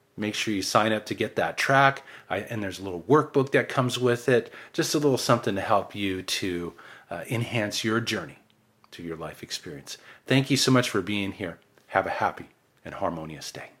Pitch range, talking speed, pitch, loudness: 95-130 Hz, 210 wpm, 110 Hz, -26 LUFS